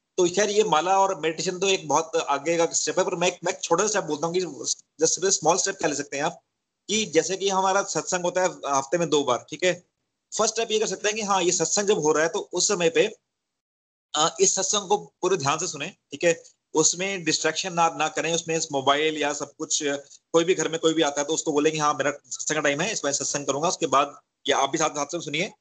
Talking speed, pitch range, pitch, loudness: 250 wpm, 150-190 Hz, 165 Hz, -24 LUFS